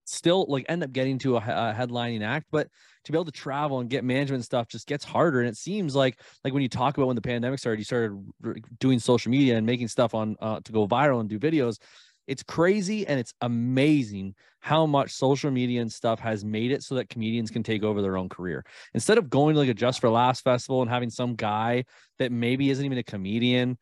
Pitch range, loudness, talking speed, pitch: 115-140 Hz, -26 LUFS, 240 wpm, 125 Hz